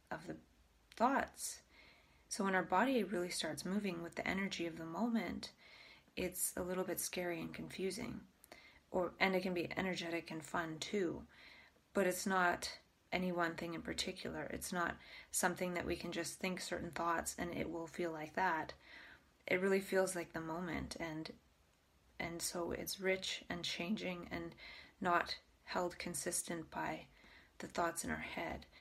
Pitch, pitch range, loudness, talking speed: 175 Hz, 165-185 Hz, -40 LUFS, 165 wpm